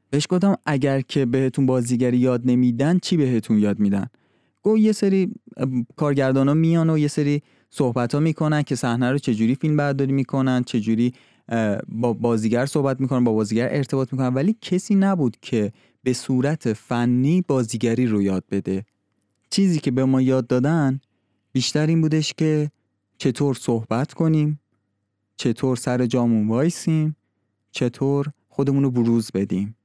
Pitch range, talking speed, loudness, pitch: 115-145 Hz, 145 wpm, -21 LUFS, 130 Hz